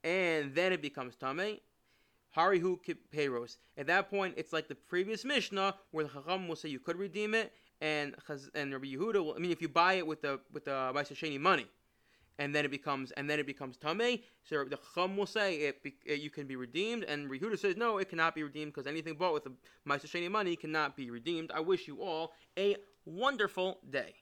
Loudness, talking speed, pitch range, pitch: -35 LUFS, 210 wpm, 145-185 Hz, 160 Hz